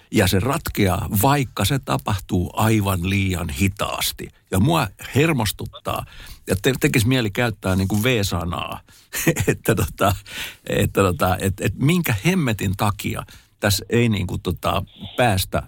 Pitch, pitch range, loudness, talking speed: 105 Hz, 95-120 Hz, -21 LUFS, 130 wpm